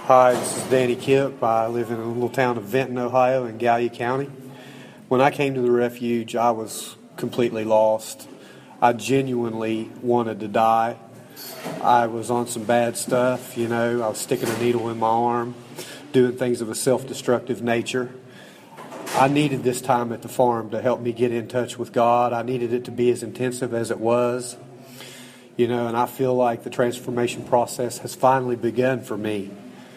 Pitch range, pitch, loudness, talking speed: 115-125 Hz, 120 Hz, -22 LUFS, 190 wpm